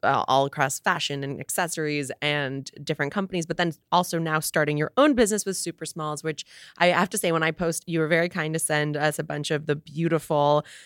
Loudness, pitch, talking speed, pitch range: -25 LUFS, 160 Hz, 220 wpm, 150-170 Hz